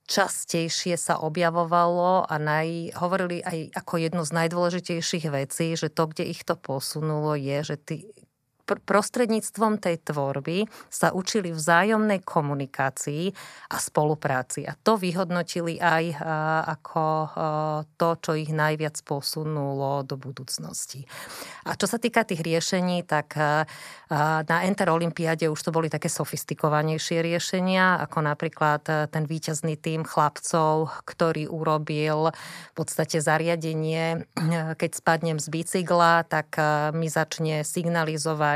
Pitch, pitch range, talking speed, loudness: 160 Hz, 155-170 Hz, 120 wpm, -25 LUFS